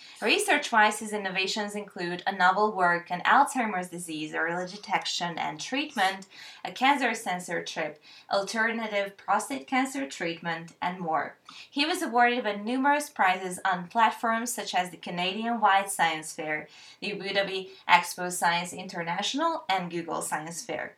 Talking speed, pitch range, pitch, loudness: 135 wpm, 175-230 Hz, 195 Hz, -27 LUFS